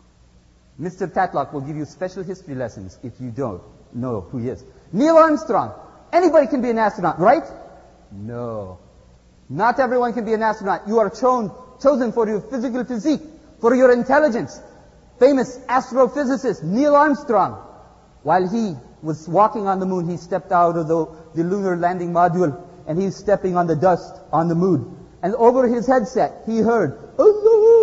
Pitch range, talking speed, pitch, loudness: 165-250 Hz, 165 wpm, 190 Hz, -19 LUFS